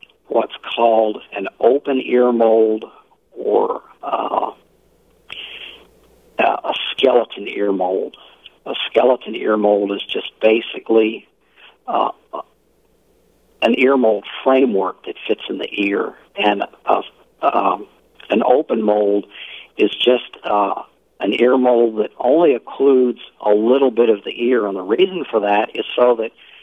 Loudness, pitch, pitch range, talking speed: -17 LUFS, 115 Hz, 105-135 Hz, 130 wpm